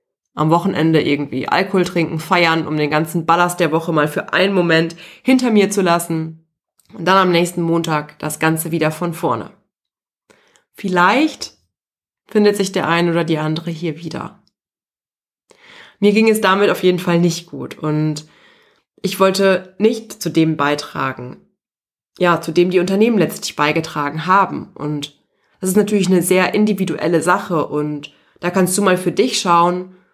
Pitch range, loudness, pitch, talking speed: 160-190 Hz, -16 LUFS, 170 Hz, 160 wpm